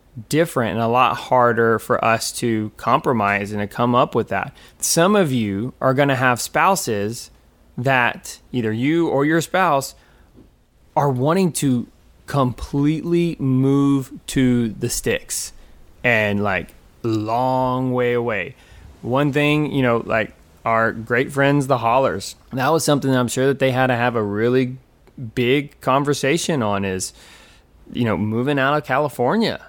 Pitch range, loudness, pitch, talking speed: 115-140 Hz, -19 LUFS, 125 Hz, 150 wpm